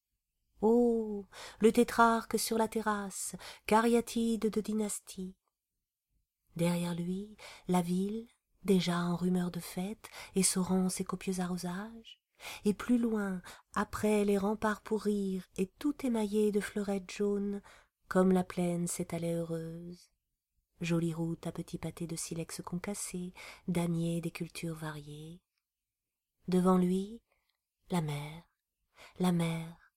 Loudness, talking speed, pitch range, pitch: -33 LUFS, 120 wpm, 170-210 Hz, 185 Hz